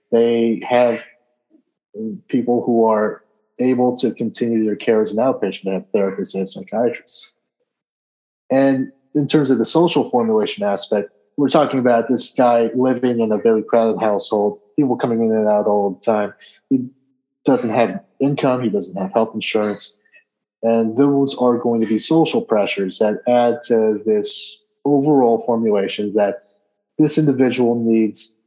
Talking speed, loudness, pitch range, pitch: 155 wpm, -18 LUFS, 110-135 Hz, 115 Hz